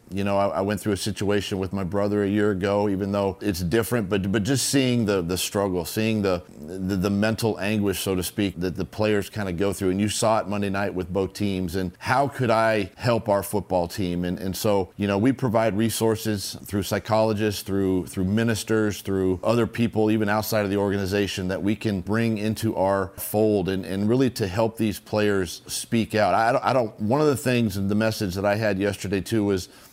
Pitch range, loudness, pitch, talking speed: 95-110 Hz, -24 LUFS, 105 Hz, 225 wpm